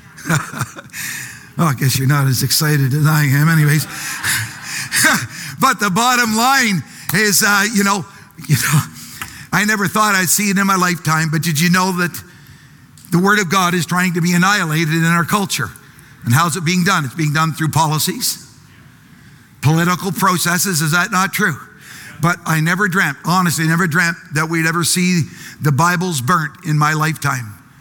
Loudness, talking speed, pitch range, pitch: -15 LUFS, 175 wpm, 150-185 Hz, 165 Hz